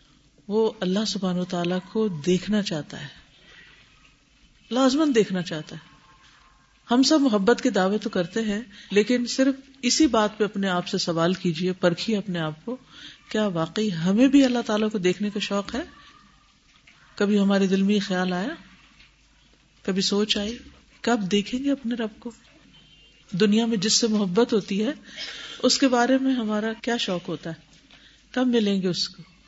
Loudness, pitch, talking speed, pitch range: -24 LUFS, 210 Hz, 165 wpm, 185-235 Hz